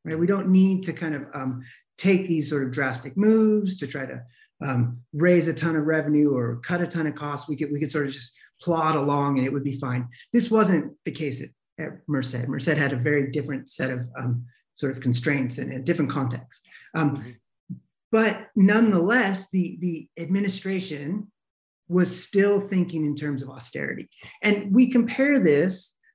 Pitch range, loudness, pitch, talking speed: 135-185 Hz, -24 LUFS, 155 Hz, 190 wpm